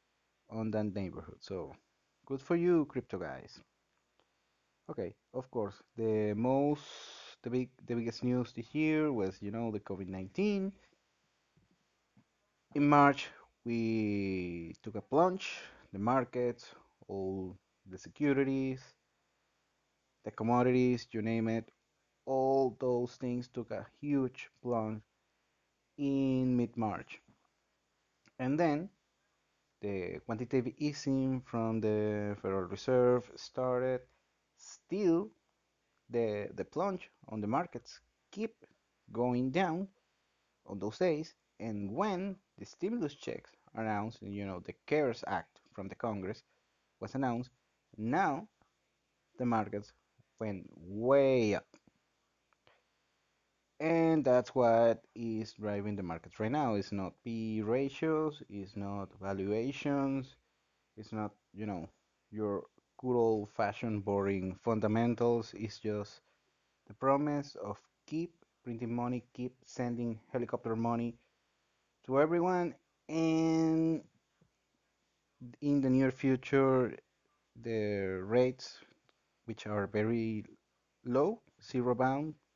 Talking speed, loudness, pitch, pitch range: 110 wpm, -34 LUFS, 120 Hz, 105-135 Hz